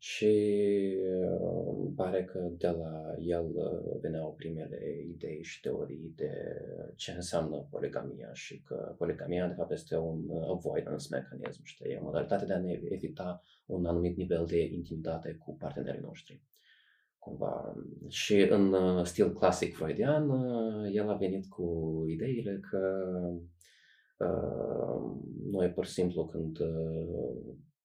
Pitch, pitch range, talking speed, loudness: 90 Hz, 85-95 Hz, 125 wpm, -34 LUFS